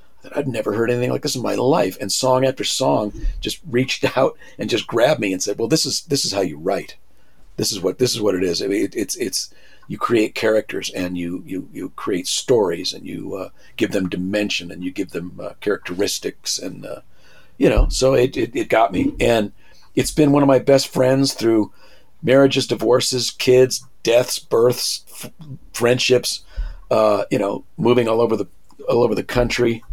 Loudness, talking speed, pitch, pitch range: -19 LUFS, 205 wpm, 120 Hz, 105-135 Hz